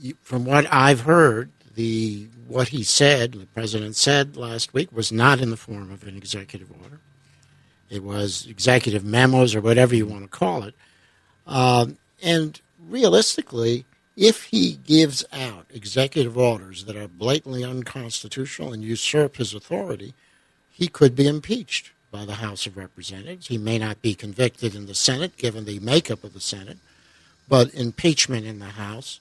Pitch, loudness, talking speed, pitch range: 120 Hz, -21 LUFS, 160 wpm, 105-140 Hz